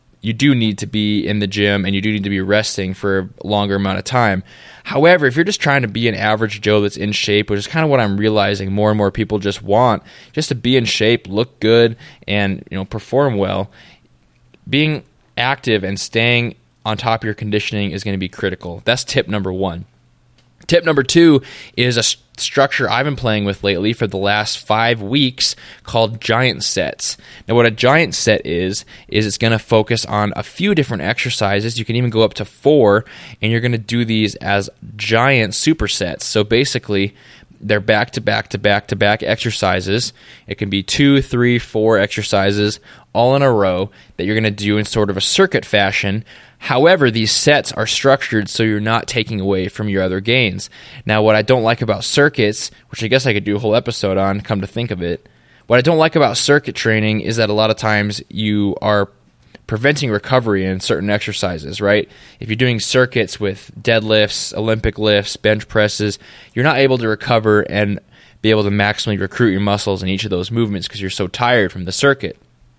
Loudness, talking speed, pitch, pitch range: -16 LUFS, 210 wpm, 110 Hz, 100-120 Hz